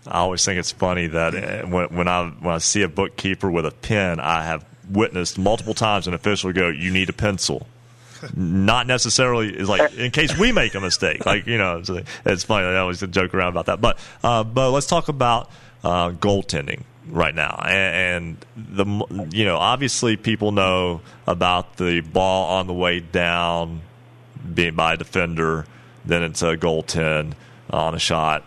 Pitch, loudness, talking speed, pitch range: 95 Hz, -20 LUFS, 185 wpm, 85-110 Hz